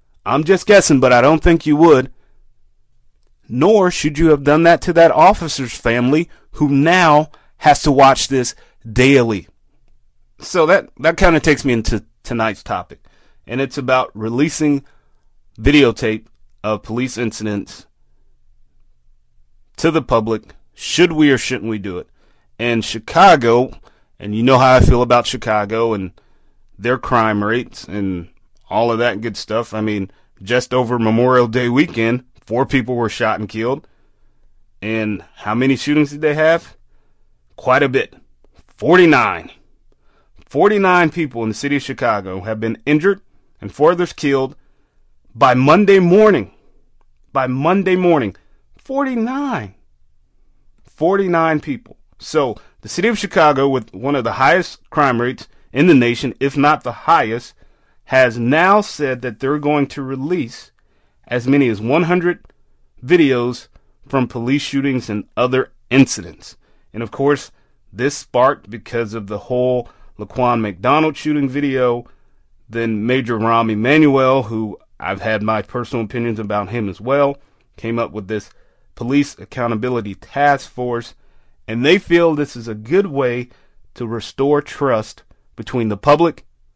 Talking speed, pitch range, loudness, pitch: 145 wpm, 110-145 Hz, -16 LUFS, 125 Hz